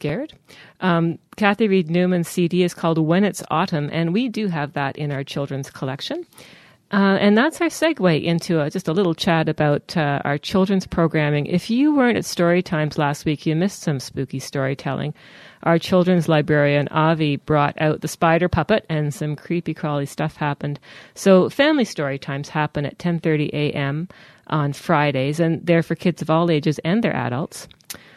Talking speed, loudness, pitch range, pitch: 180 wpm, -20 LUFS, 145-180 Hz, 160 Hz